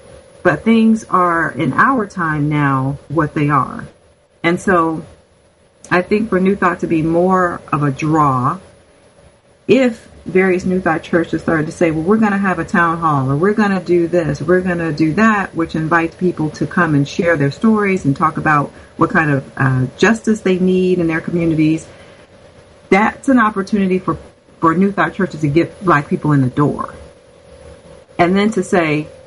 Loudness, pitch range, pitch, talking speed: -15 LUFS, 155-190 Hz, 170 Hz, 190 wpm